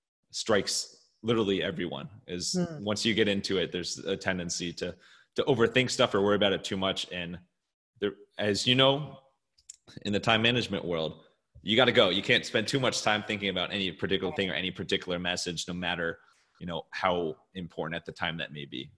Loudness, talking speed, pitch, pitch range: -29 LUFS, 200 wpm, 100 Hz, 90-115 Hz